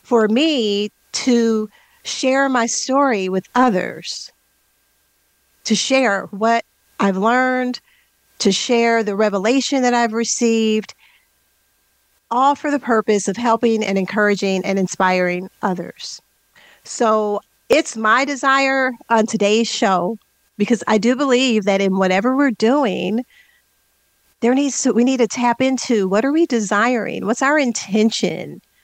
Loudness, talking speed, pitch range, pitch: -17 LUFS, 130 wpm, 210-255 Hz, 230 Hz